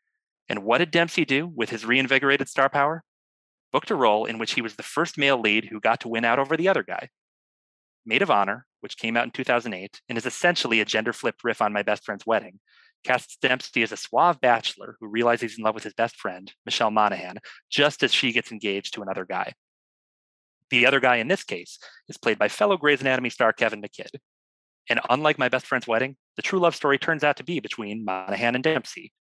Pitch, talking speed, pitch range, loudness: 130 Hz, 220 wpm, 110-160 Hz, -23 LUFS